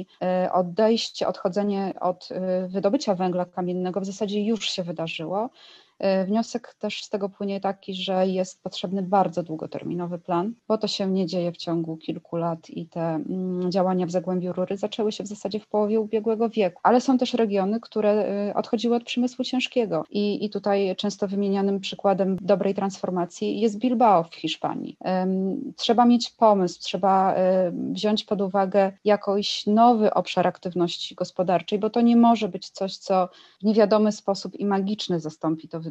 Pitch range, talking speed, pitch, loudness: 185-215 Hz, 155 wpm, 195 Hz, -24 LUFS